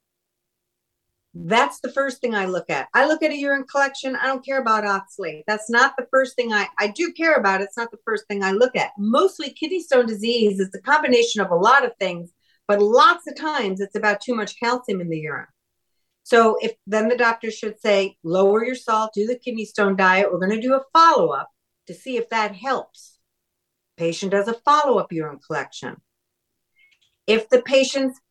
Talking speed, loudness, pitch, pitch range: 210 wpm, -20 LUFS, 230 Hz, 200-265 Hz